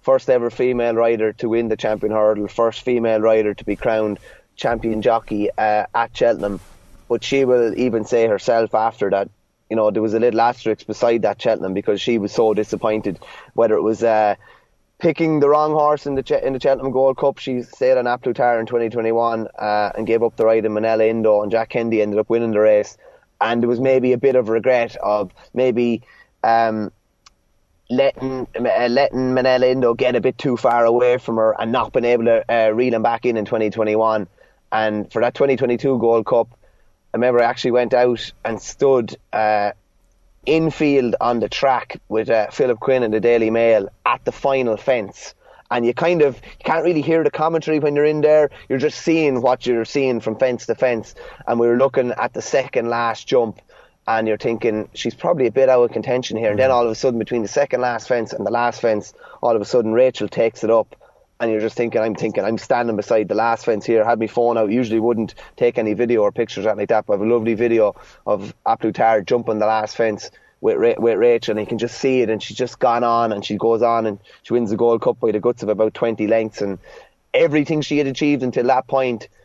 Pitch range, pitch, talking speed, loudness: 110-130 Hz, 115 Hz, 225 wpm, -18 LUFS